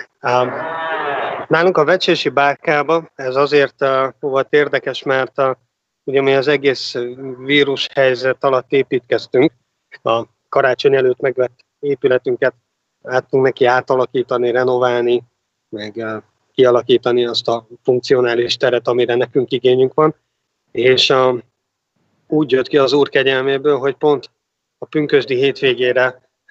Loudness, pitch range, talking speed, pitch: -16 LUFS, 125-145 Hz, 120 wpm, 130 Hz